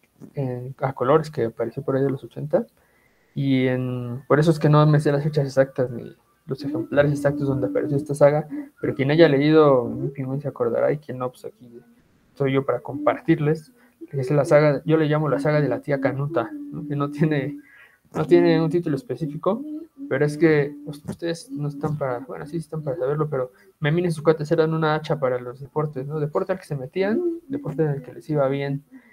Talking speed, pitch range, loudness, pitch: 215 wpm, 135-160 Hz, -22 LUFS, 145 Hz